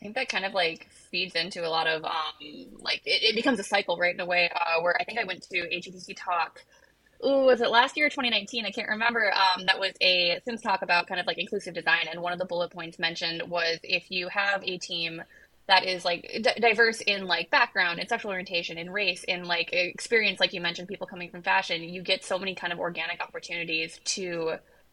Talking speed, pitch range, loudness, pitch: 235 wpm, 175-200 Hz, -26 LUFS, 180 Hz